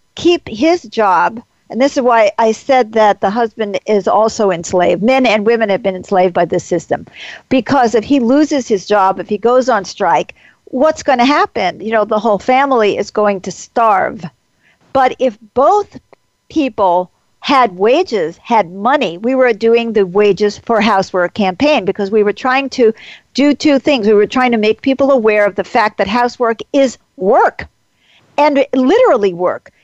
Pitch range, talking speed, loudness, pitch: 205-265 Hz, 180 wpm, -13 LUFS, 230 Hz